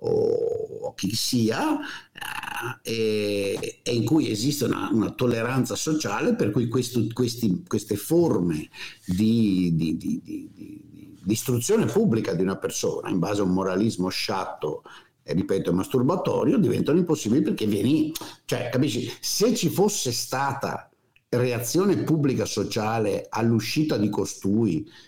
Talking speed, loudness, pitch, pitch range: 130 wpm, -25 LUFS, 125 Hz, 110-165 Hz